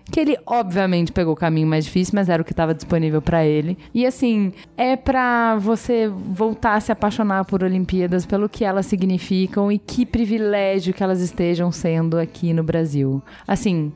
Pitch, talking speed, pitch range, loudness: 190 Hz, 180 wpm, 170-215 Hz, -20 LUFS